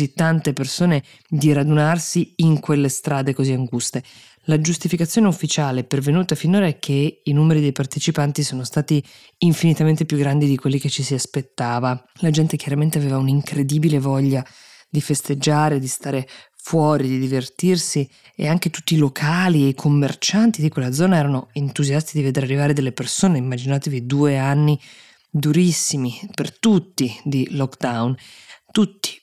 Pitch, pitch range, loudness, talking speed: 145 Hz, 135-160 Hz, -19 LUFS, 145 wpm